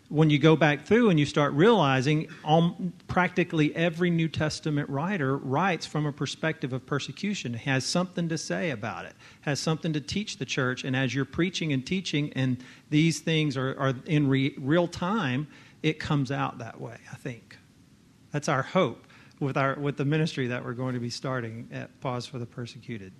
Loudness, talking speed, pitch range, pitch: -27 LUFS, 190 wpm, 130-165 Hz, 145 Hz